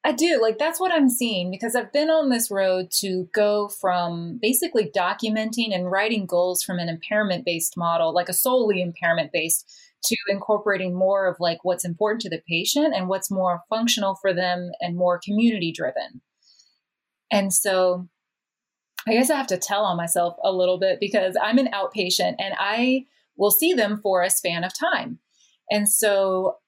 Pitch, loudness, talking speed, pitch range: 195 Hz, -22 LUFS, 175 wpm, 180-230 Hz